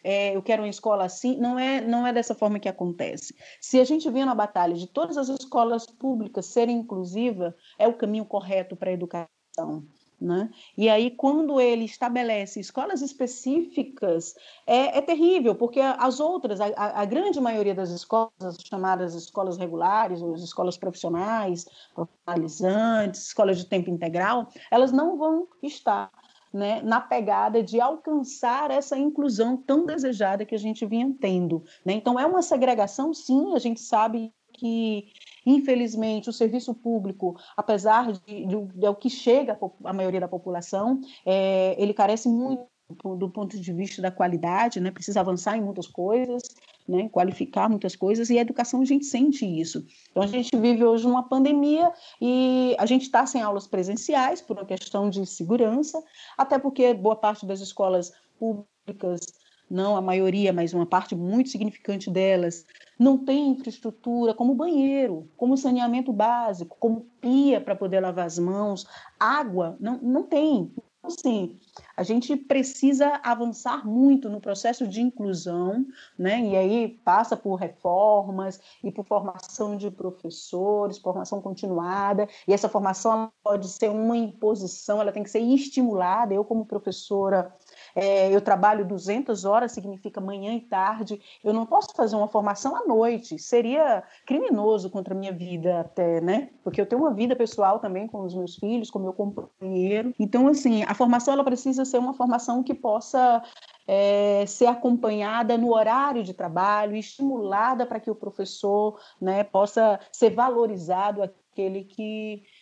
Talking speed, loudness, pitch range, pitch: 160 wpm, -25 LUFS, 195-250 Hz, 220 Hz